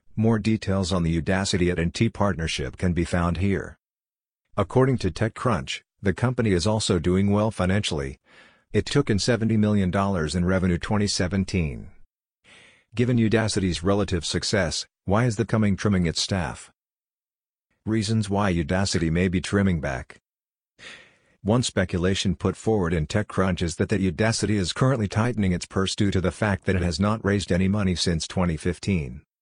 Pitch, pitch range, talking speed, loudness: 95 Hz, 90-110 Hz, 155 wpm, -24 LUFS